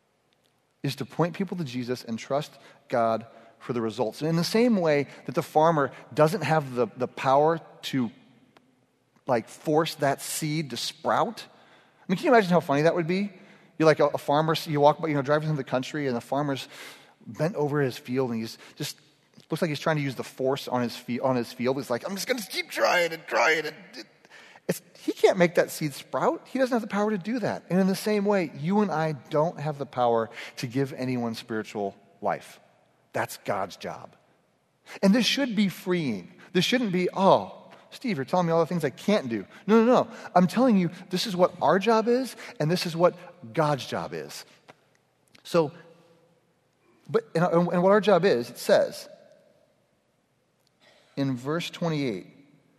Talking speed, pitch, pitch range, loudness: 200 wpm, 155 Hz, 135-185 Hz, -26 LUFS